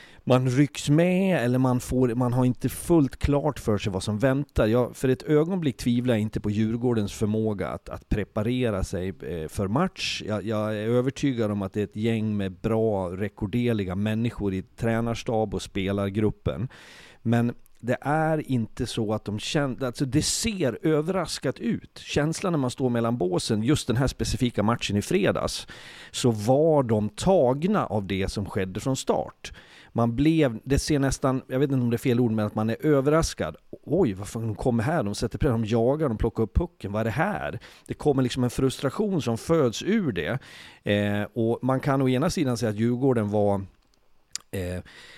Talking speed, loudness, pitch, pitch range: 190 wpm, -25 LUFS, 120 Hz, 105-135 Hz